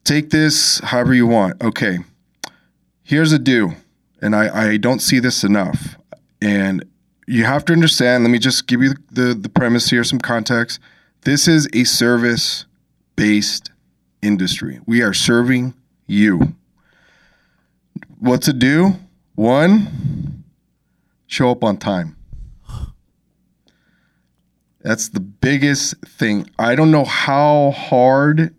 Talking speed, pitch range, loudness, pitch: 125 wpm, 110-145 Hz, -15 LUFS, 125 Hz